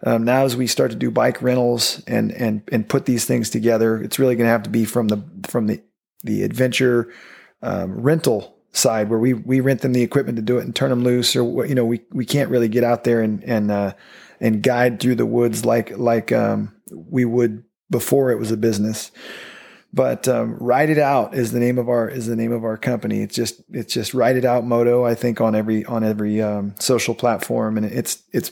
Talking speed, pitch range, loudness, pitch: 235 wpm, 115-125 Hz, -19 LUFS, 120 Hz